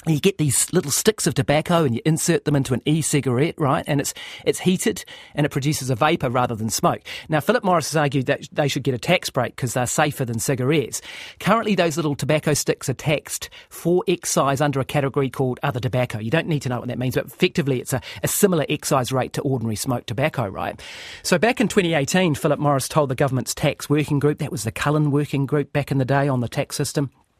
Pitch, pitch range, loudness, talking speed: 145 Hz, 135-160 Hz, -21 LUFS, 235 wpm